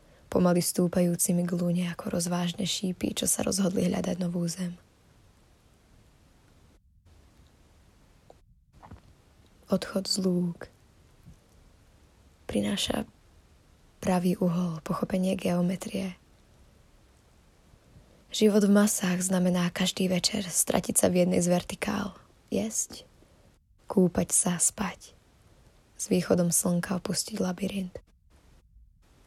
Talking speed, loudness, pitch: 85 wpm, -27 LUFS, 175 Hz